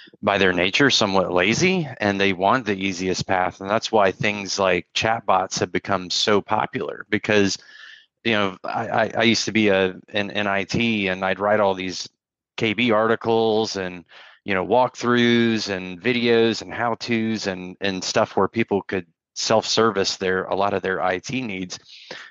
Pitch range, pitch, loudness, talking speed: 95-115 Hz, 100 Hz, -21 LUFS, 170 wpm